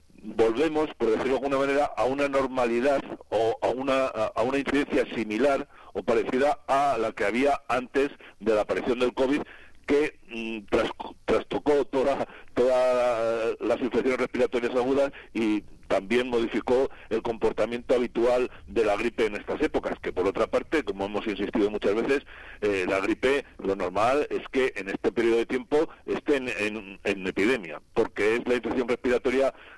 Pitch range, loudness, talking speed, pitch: 120-140 Hz, -26 LUFS, 165 wpm, 125 Hz